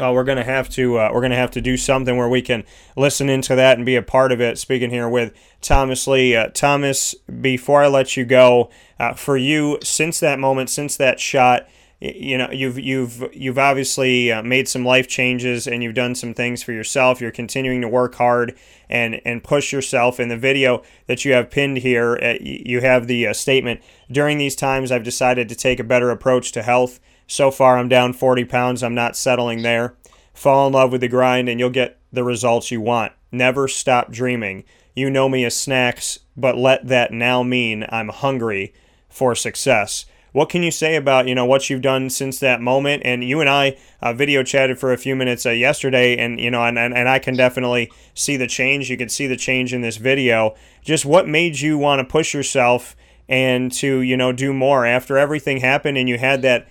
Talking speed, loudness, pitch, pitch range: 215 wpm, -17 LUFS, 125 Hz, 120-135 Hz